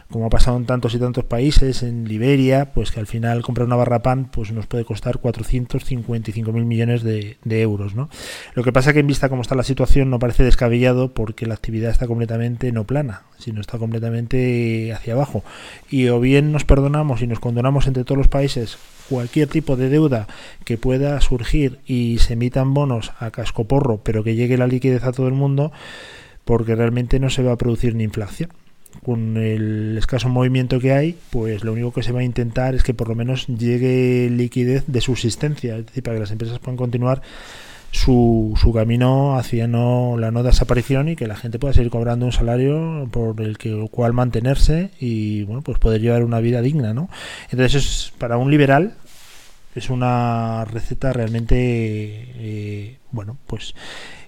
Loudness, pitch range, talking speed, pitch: -20 LUFS, 115-130 Hz, 190 wpm, 120 Hz